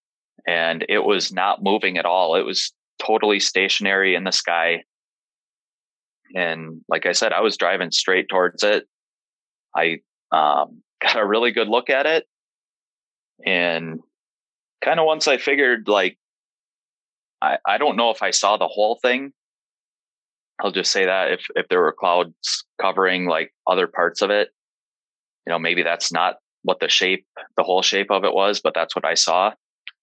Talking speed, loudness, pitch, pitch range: 170 wpm, -20 LUFS, 90 Hz, 85-100 Hz